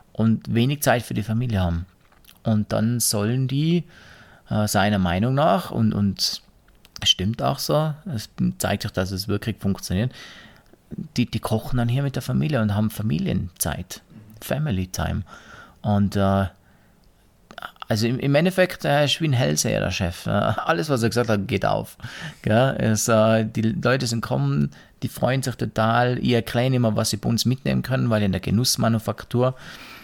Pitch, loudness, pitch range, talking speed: 110 Hz, -22 LUFS, 100-125 Hz, 165 wpm